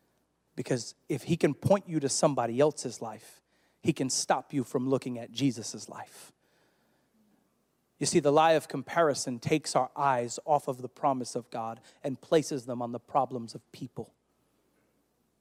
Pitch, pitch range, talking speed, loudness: 135 Hz, 125-155 Hz, 165 wpm, -30 LUFS